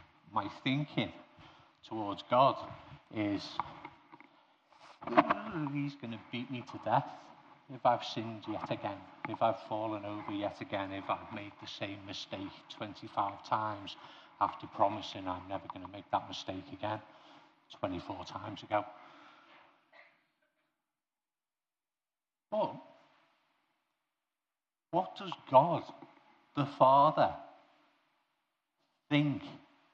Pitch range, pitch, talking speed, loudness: 100-130 Hz, 110 Hz, 105 wpm, -35 LUFS